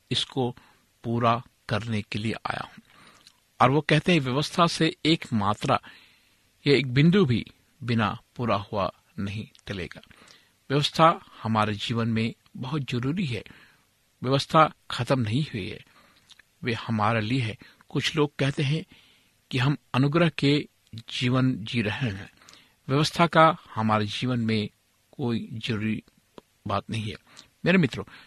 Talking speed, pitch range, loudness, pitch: 135 wpm, 110-145 Hz, -26 LUFS, 125 Hz